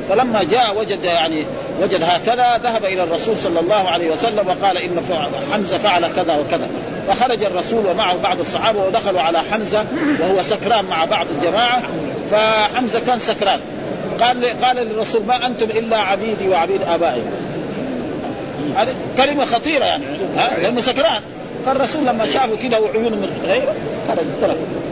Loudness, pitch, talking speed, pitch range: -17 LUFS, 220 Hz, 145 wpm, 195-245 Hz